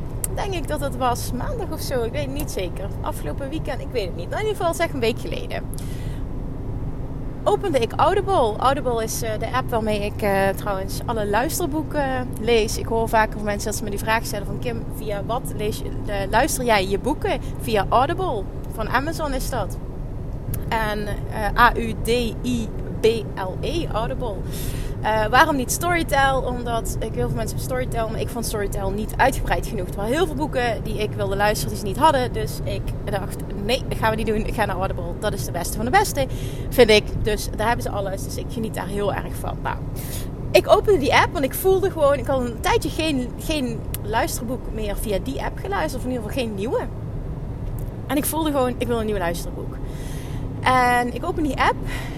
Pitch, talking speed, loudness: 205 Hz, 205 wpm, -23 LUFS